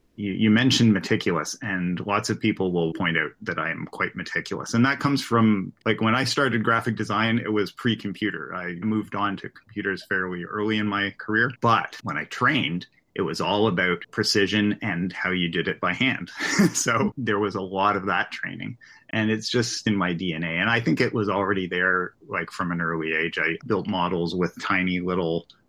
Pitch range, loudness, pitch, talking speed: 90-110 Hz, -24 LUFS, 100 Hz, 205 wpm